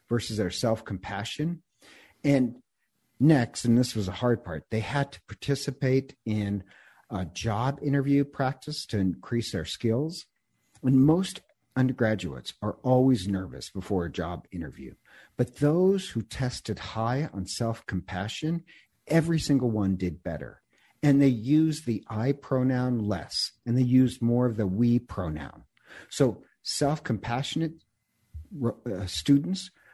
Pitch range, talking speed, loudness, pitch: 100-140 Hz, 135 wpm, -28 LUFS, 120 Hz